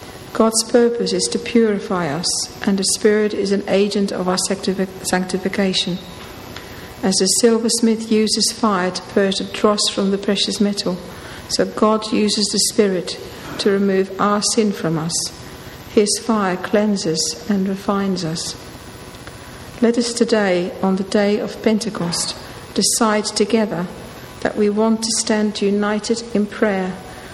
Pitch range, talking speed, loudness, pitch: 190-220 Hz, 140 wpm, -18 LUFS, 205 Hz